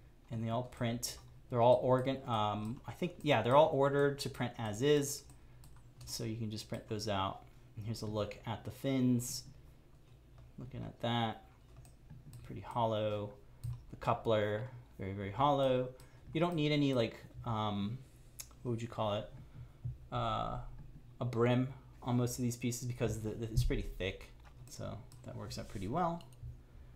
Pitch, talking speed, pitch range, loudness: 120 Hz, 165 wpm, 110-130 Hz, -36 LUFS